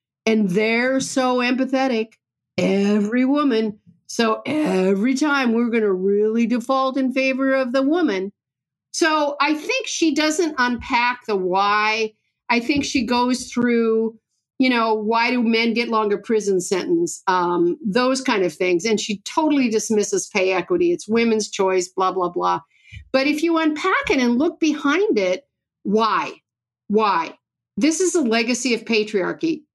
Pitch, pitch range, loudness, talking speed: 230 Hz, 200-270 Hz, -20 LUFS, 150 wpm